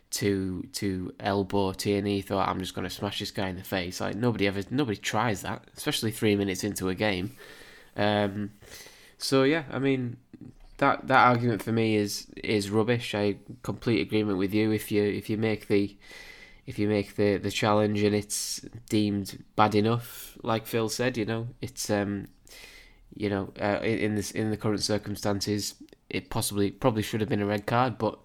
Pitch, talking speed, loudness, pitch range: 105 Hz, 185 wpm, -28 LUFS, 100-110 Hz